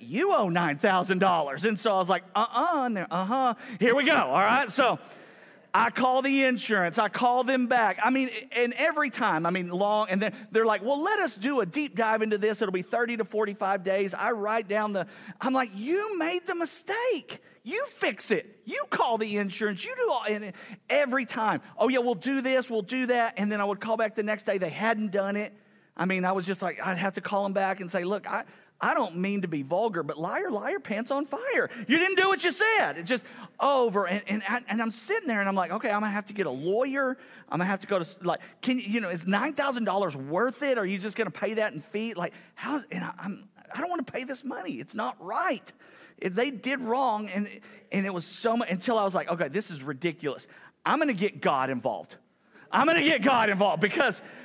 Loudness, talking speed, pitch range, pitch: -27 LUFS, 240 wpm, 195-255 Hz, 215 Hz